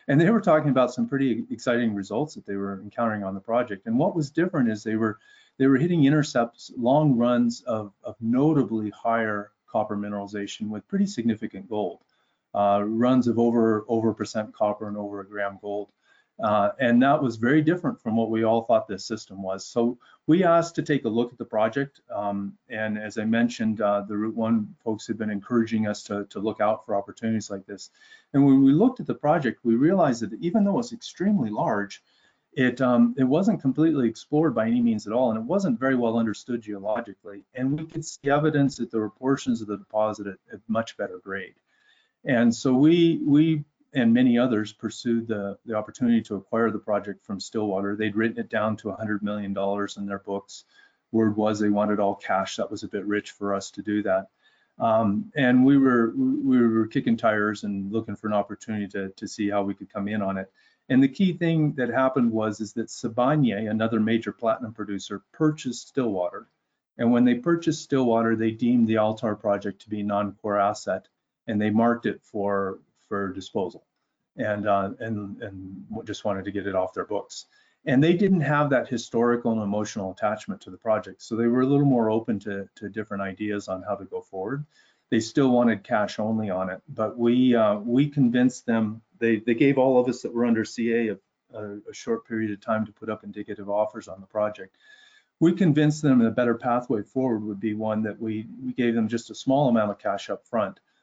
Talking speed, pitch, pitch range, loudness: 210 wpm, 110 Hz, 105-130 Hz, -25 LUFS